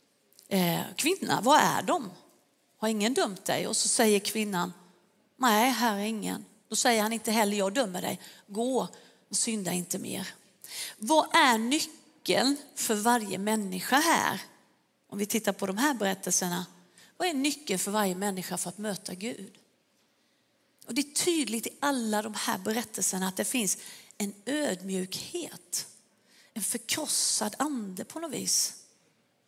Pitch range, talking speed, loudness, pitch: 195-260 Hz, 150 wpm, -28 LUFS, 220 Hz